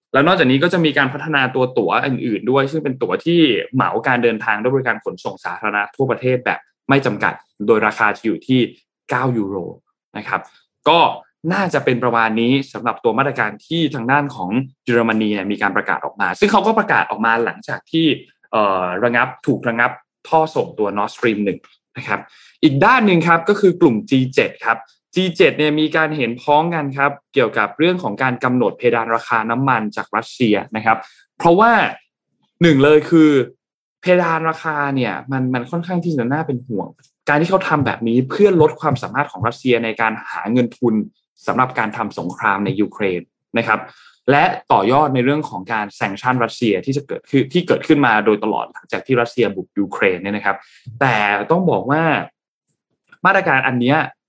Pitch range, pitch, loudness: 115-155 Hz, 130 Hz, -17 LUFS